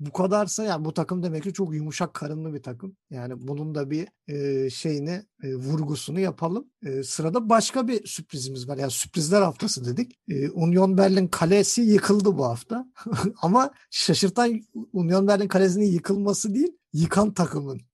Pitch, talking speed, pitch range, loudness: 180 Hz, 145 wpm, 150-205 Hz, -24 LUFS